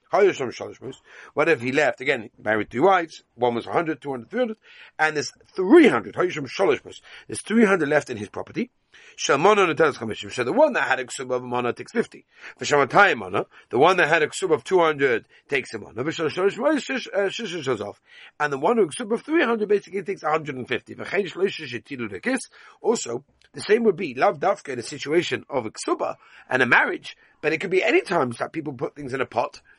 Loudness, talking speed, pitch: -23 LUFS, 175 wpm, 185 Hz